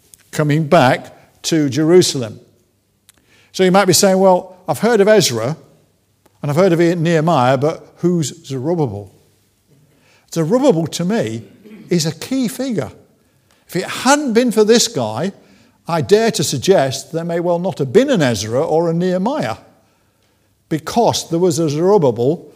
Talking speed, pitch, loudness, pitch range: 150 wpm, 165 Hz, -15 LUFS, 130-190 Hz